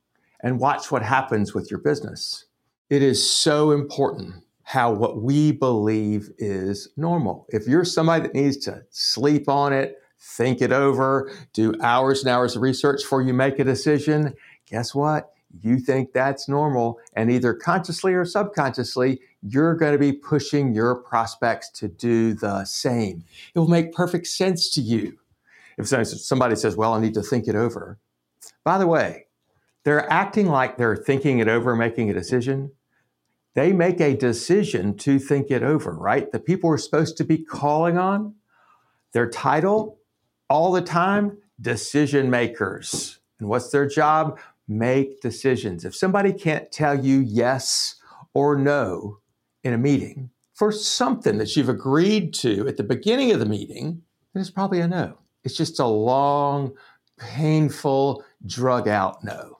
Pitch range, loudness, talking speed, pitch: 120-155 Hz, -22 LUFS, 160 wpm, 135 Hz